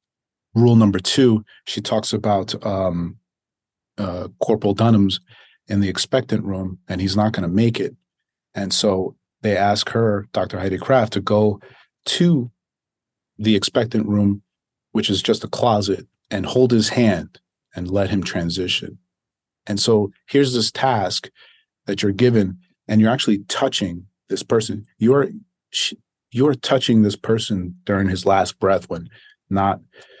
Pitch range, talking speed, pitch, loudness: 95-115 Hz, 145 wpm, 105 Hz, -19 LUFS